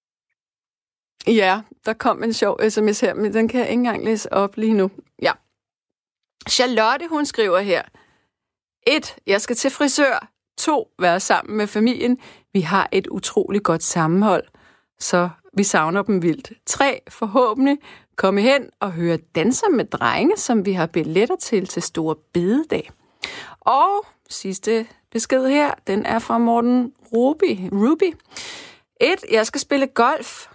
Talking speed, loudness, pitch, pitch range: 145 wpm, -20 LUFS, 225 Hz, 195-275 Hz